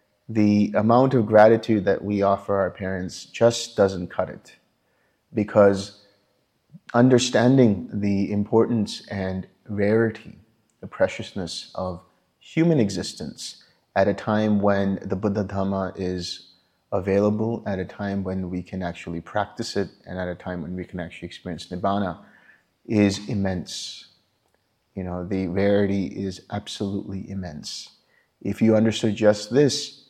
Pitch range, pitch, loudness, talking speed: 95-110 Hz, 100 Hz, -23 LUFS, 130 wpm